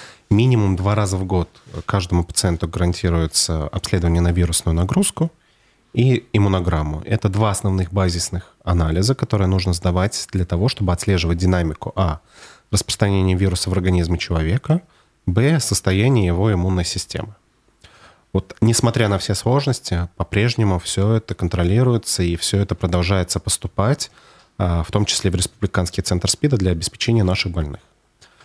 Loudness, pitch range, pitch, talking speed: -19 LUFS, 90-110 Hz, 95 Hz, 135 wpm